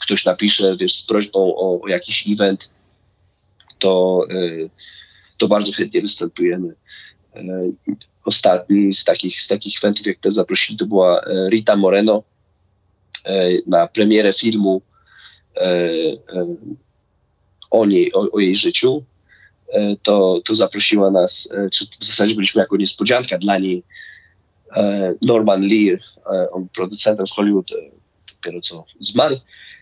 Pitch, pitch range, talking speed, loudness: 100 Hz, 95-105 Hz, 110 wpm, -17 LUFS